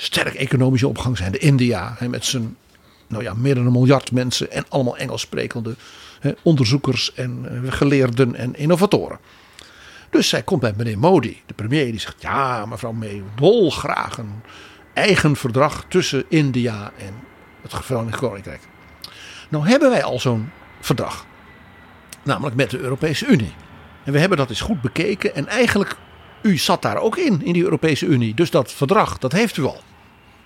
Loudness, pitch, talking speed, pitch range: -19 LUFS, 125 Hz, 165 wpm, 105-145 Hz